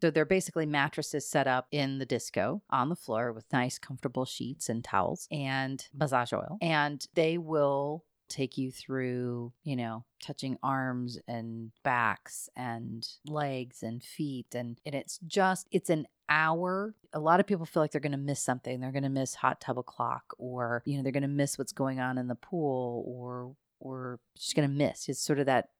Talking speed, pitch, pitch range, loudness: 200 wpm, 135 Hz, 125-155 Hz, -32 LUFS